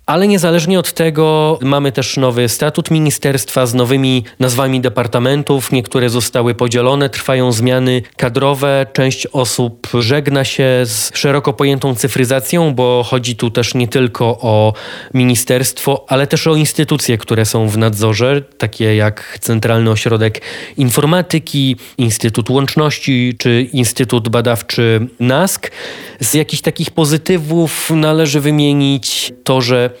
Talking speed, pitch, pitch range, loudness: 125 wpm, 130 Hz, 120-145 Hz, -13 LUFS